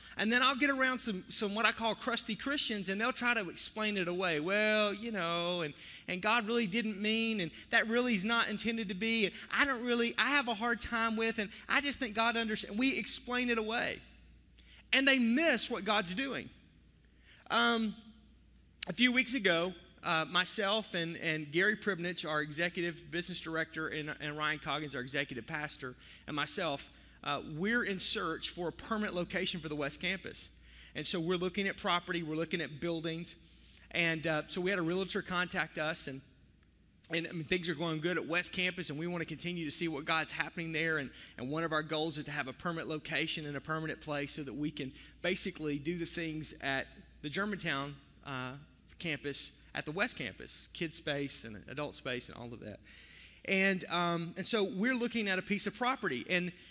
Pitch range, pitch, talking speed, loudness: 155-215 Hz, 175 Hz, 205 wpm, -34 LUFS